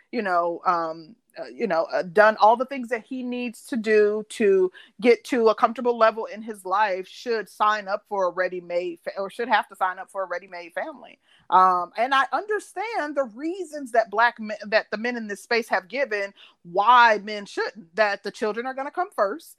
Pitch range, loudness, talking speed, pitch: 200-250 Hz, -23 LUFS, 215 wpm, 220 Hz